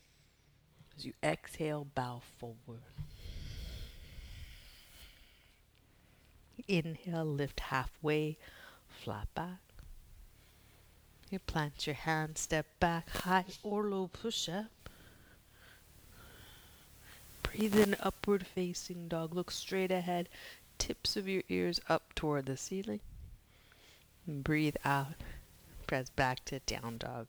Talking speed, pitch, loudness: 100 wpm, 150 Hz, -37 LUFS